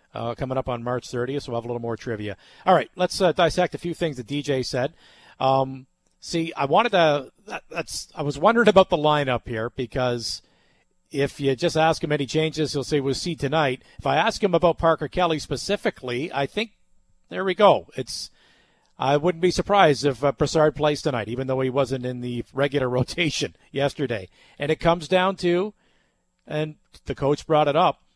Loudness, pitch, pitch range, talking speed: -23 LUFS, 145 Hz, 130-170 Hz, 200 wpm